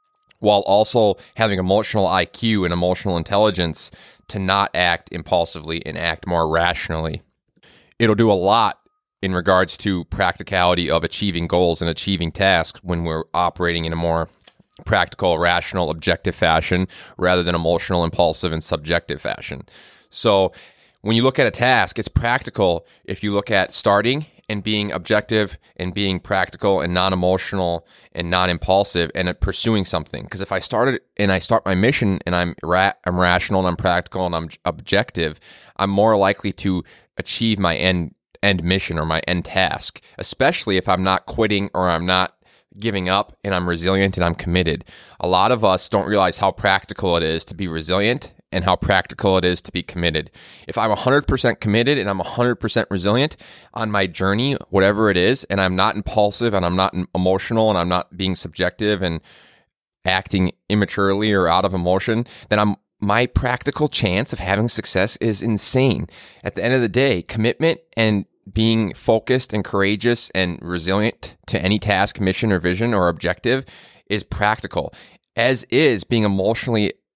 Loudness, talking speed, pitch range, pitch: -19 LUFS, 165 wpm, 90-105 Hz, 95 Hz